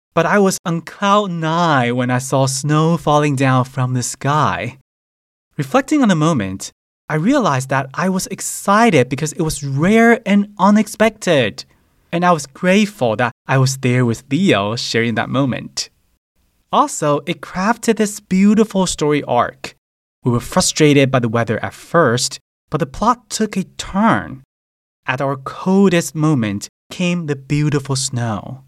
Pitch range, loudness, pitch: 125-190 Hz, -16 LUFS, 150 Hz